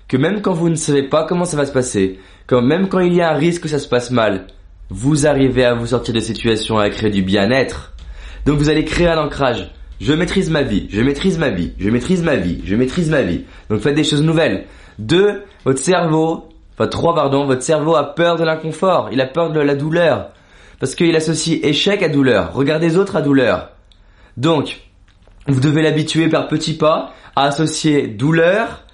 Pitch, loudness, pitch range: 145 Hz, -16 LUFS, 115-160 Hz